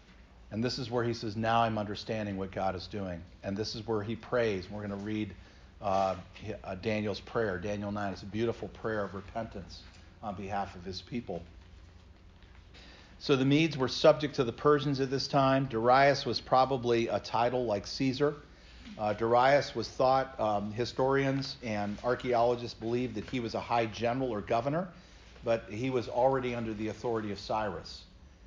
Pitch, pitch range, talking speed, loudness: 110 Hz, 100-125 Hz, 175 wpm, -31 LUFS